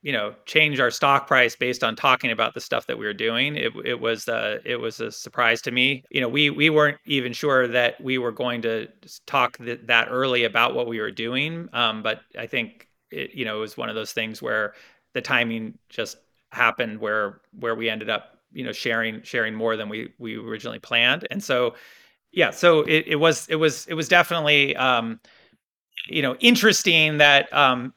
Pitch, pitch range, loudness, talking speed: 125 Hz, 115-145 Hz, -21 LUFS, 210 wpm